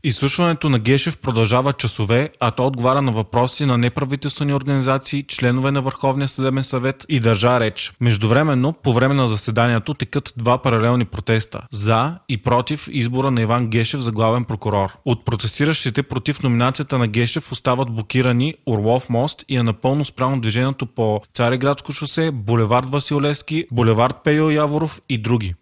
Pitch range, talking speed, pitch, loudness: 120-140 Hz, 150 wpm, 130 Hz, -19 LUFS